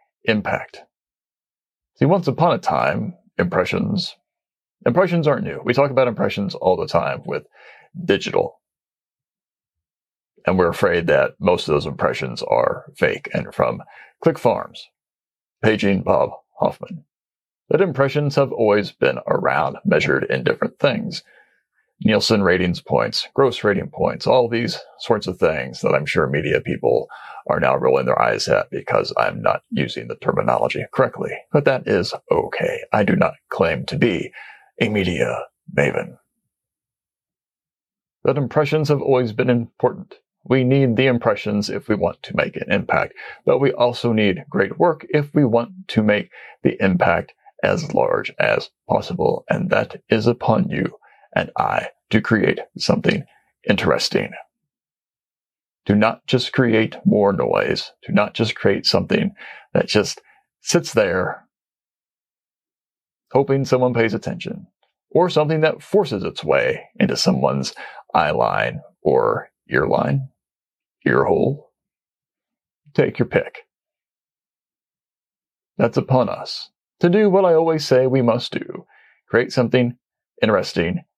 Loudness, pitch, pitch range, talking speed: -19 LUFS, 130 Hz, 115-170 Hz, 135 wpm